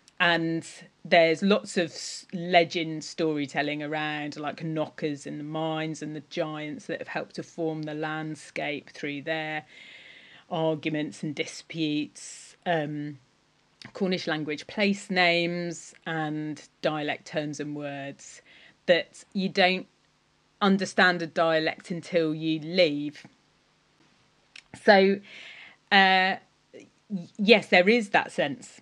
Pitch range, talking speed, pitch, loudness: 150-180 Hz, 110 wpm, 160 Hz, -26 LUFS